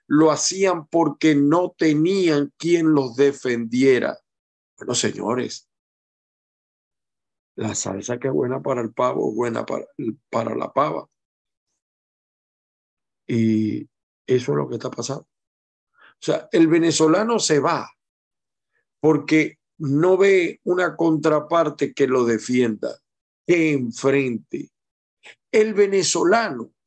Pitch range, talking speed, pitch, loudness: 120-165 Hz, 110 wpm, 145 Hz, -20 LUFS